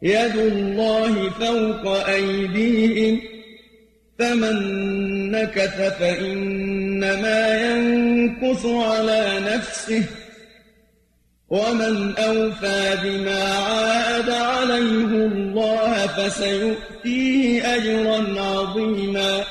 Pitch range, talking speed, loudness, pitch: 195-225 Hz, 60 wpm, -20 LUFS, 220 Hz